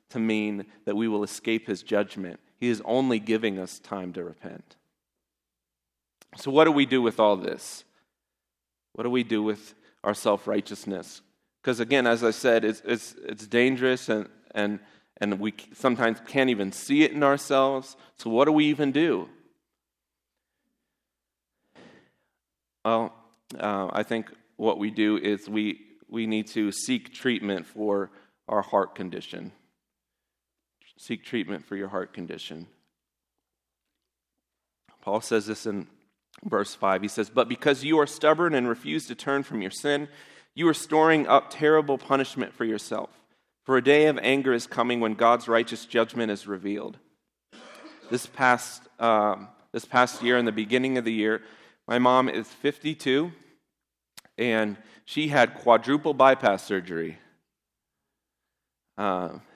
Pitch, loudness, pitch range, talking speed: 115 Hz, -25 LUFS, 105-130 Hz, 145 wpm